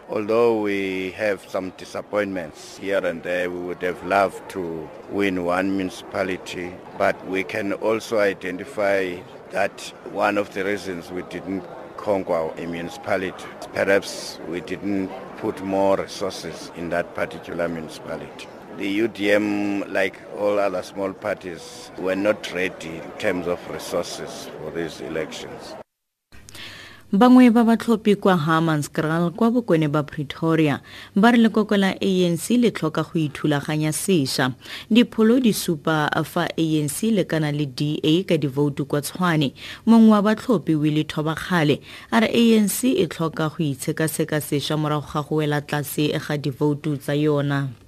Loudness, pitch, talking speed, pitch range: -22 LUFS, 150 Hz, 155 wpm, 100-165 Hz